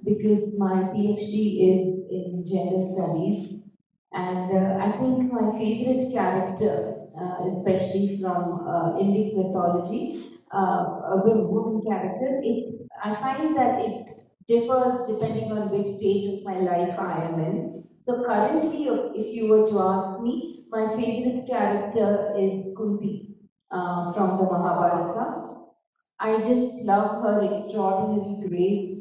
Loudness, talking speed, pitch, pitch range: -25 LUFS, 130 wpm, 205 Hz, 185-225 Hz